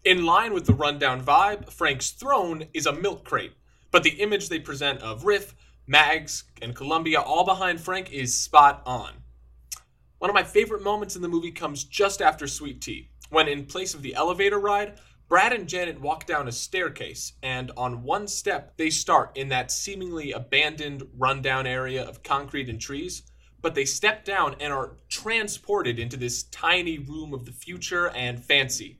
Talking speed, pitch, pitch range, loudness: 180 wpm, 150 Hz, 130-185 Hz, -24 LUFS